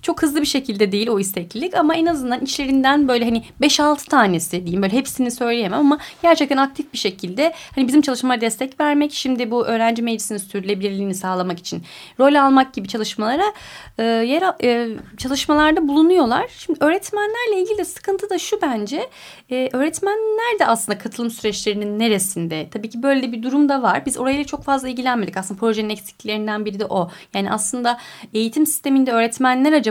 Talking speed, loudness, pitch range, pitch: 170 wpm, -19 LUFS, 220-300 Hz, 255 Hz